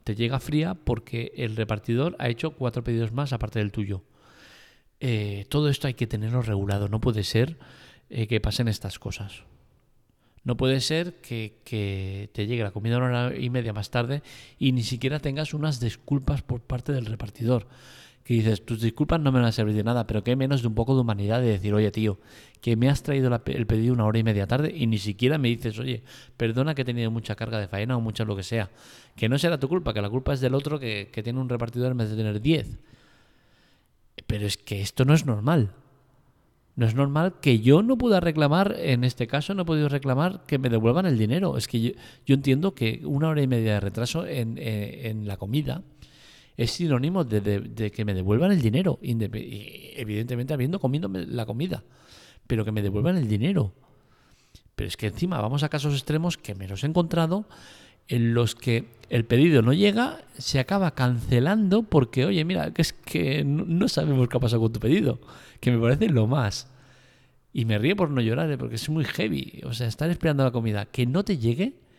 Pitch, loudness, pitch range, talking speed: 125 Hz, -25 LUFS, 110-140 Hz, 215 wpm